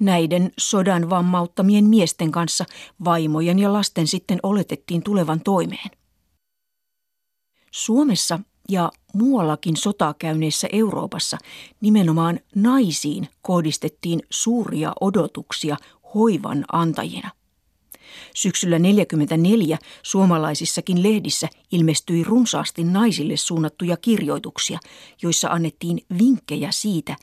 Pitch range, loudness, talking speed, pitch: 165-210 Hz, -20 LUFS, 85 wpm, 180 Hz